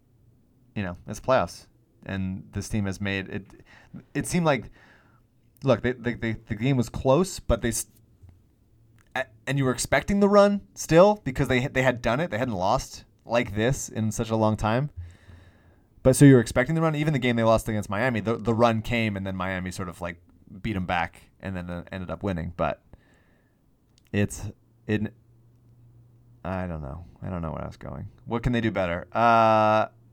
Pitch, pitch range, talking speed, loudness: 115 Hz, 100-125 Hz, 195 wpm, -25 LUFS